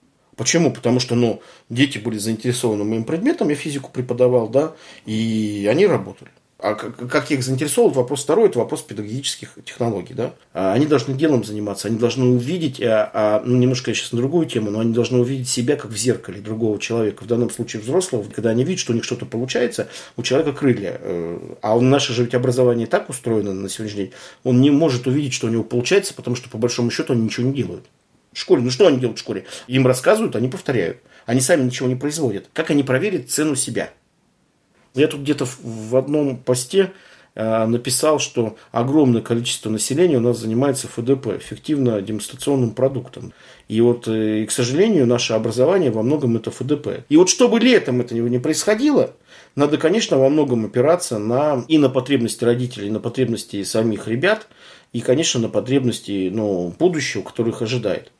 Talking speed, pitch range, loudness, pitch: 190 wpm, 115-140 Hz, -19 LUFS, 125 Hz